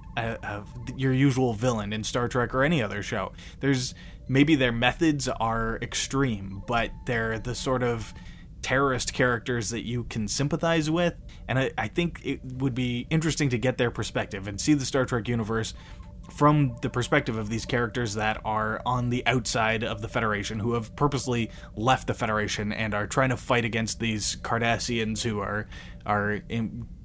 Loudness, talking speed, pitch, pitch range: -27 LUFS, 175 wpm, 120 Hz, 110-130 Hz